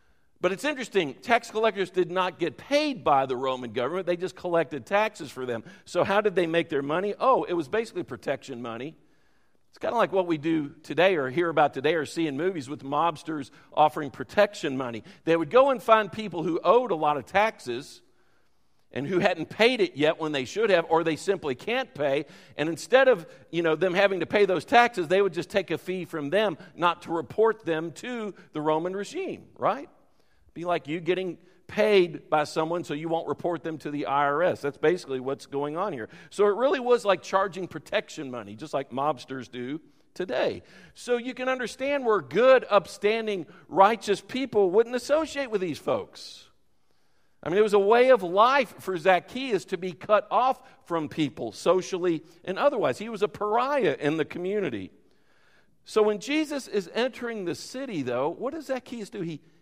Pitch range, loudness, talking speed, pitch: 155-220 Hz, -26 LUFS, 195 wpm, 185 Hz